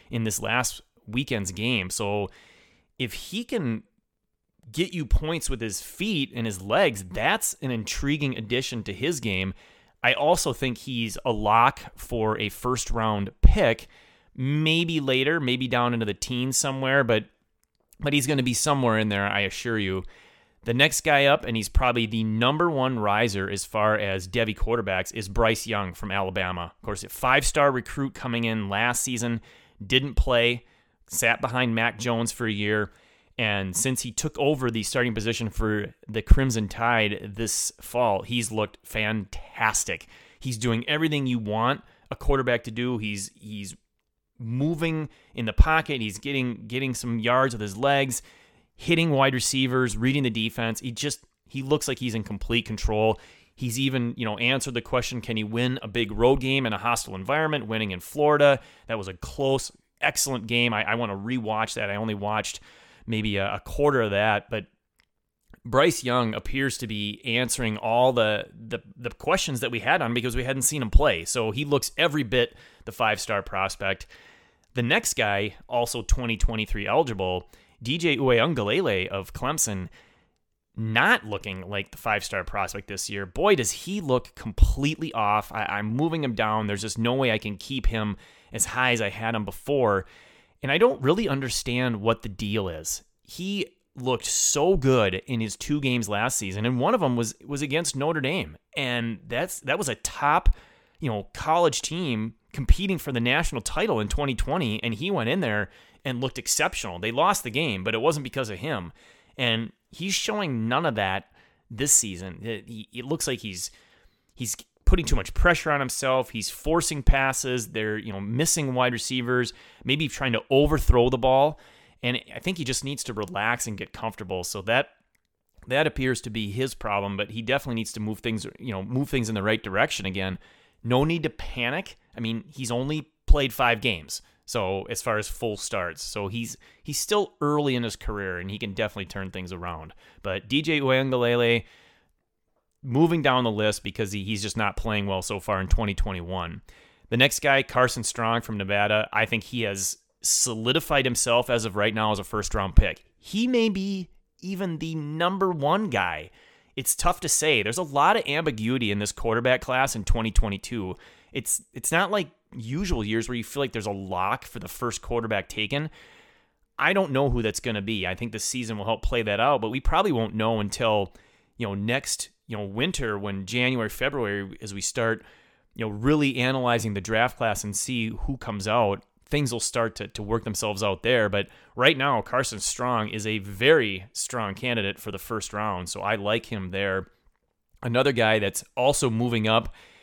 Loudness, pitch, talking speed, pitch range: -25 LUFS, 115 Hz, 185 wpm, 105-130 Hz